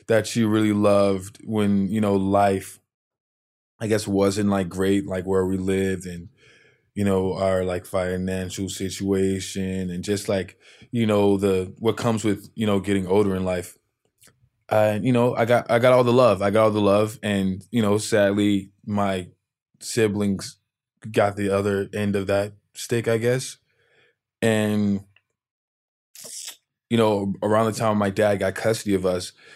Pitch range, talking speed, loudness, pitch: 95-110 Hz, 165 wpm, -22 LUFS, 100 Hz